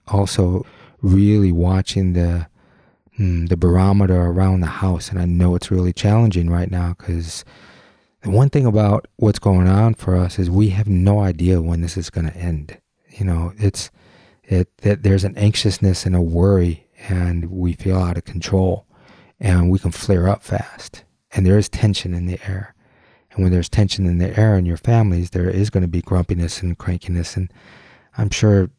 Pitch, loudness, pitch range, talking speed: 95 Hz, -18 LUFS, 90-100 Hz, 190 wpm